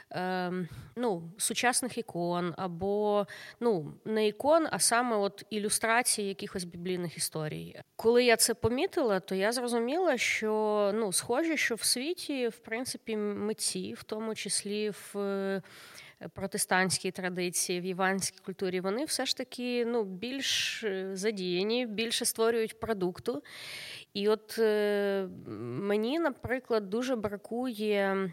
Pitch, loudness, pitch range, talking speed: 210 Hz, -31 LUFS, 190-235 Hz, 115 wpm